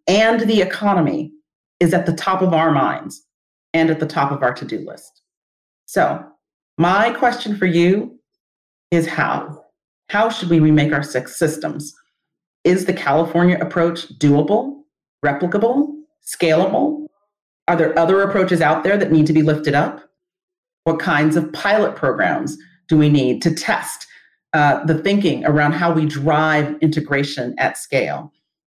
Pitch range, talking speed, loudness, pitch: 155-195 Hz, 150 wpm, -17 LUFS, 165 Hz